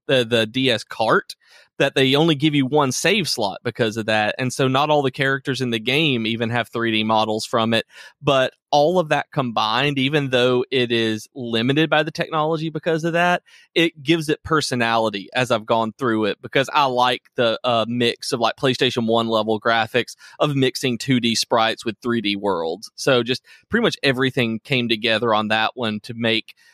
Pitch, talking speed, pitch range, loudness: 125 Hz, 195 wpm, 115-145 Hz, -20 LUFS